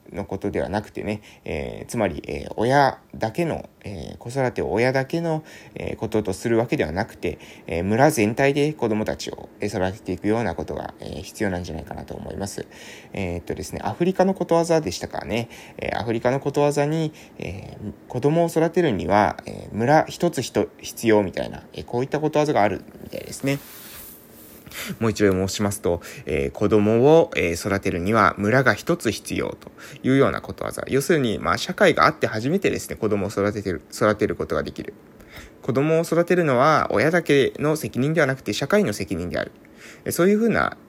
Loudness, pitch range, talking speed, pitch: -22 LUFS, 100-145 Hz, 370 characters per minute, 115 Hz